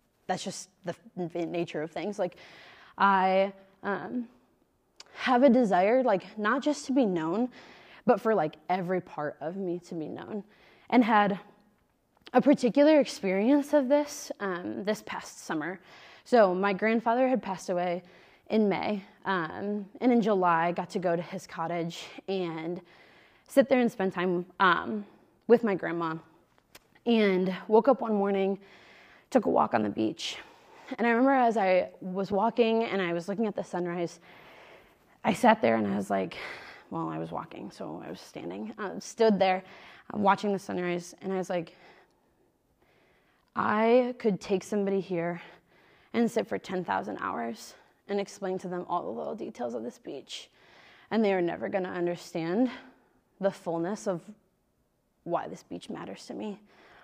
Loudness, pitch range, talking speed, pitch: -28 LUFS, 175-220 Hz, 165 wpm, 195 Hz